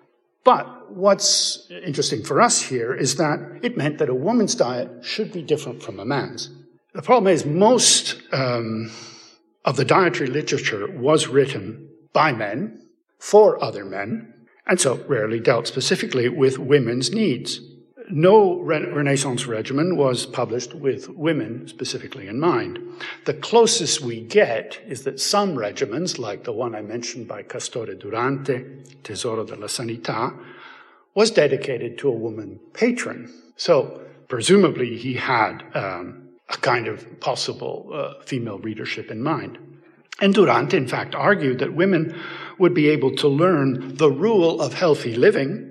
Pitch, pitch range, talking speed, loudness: 145 Hz, 125-200 Hz, 145 wpm, -21 LUFS